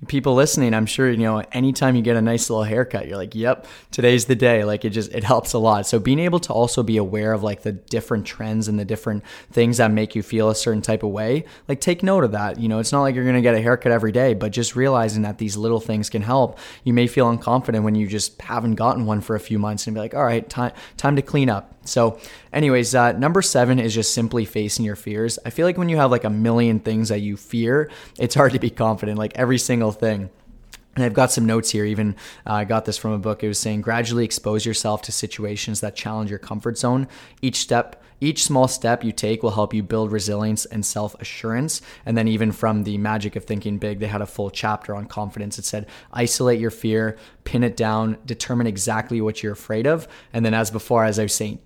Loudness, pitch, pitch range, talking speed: -21 LUFS, 115 Hz, 110-125 Hz, 250 wpm